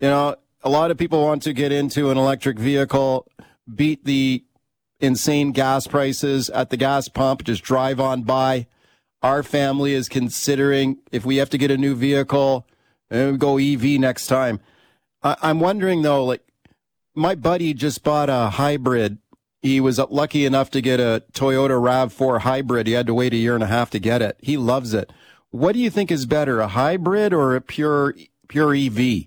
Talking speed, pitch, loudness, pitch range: 185 wpm, 135 Hz, -20 LUFS, 130-145 Hz